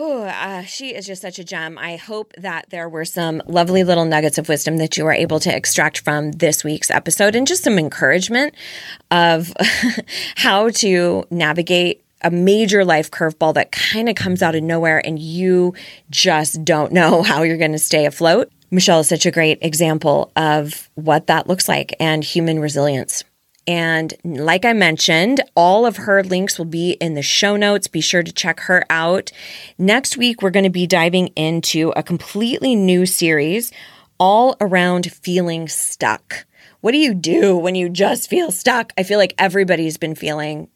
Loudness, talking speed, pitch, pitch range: -16 LUFS, 185 wpm, 175 Hz, 160-195 Hz